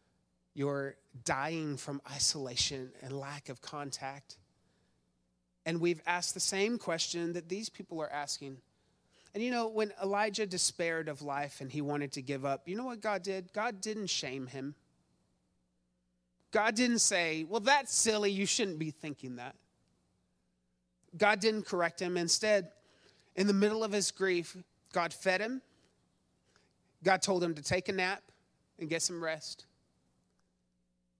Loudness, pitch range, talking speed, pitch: -33 LUFS, 135-195 Hz, 150 wpm, 165 Hz